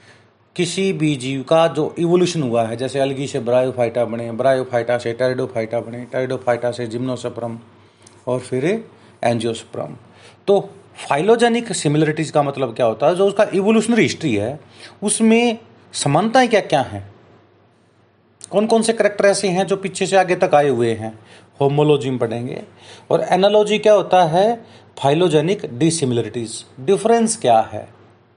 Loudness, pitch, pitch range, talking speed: -18 LUFS, 135 Hz, 120-190 Hz, 140 wpm